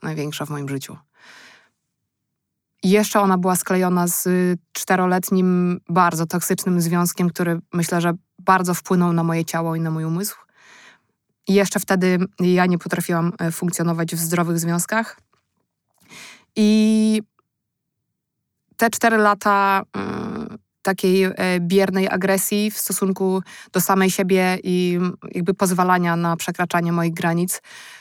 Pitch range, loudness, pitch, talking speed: 175-195 Hz, -20 LUFS, 180 Hz, 120 wpm